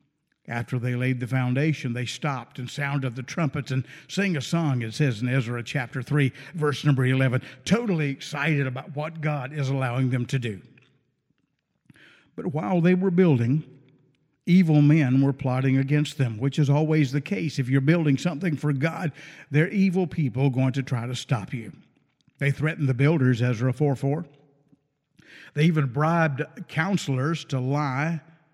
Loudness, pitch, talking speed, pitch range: -25 LUFS, 145 Hz, 165 wpm, 130-155 Hz